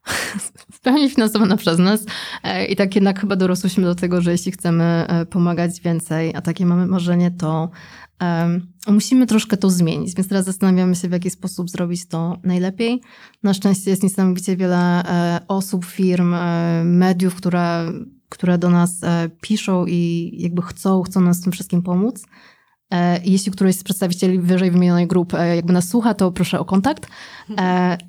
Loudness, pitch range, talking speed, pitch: -18 LUFS, 175-195 Hz, 170 wpm, 180 Hz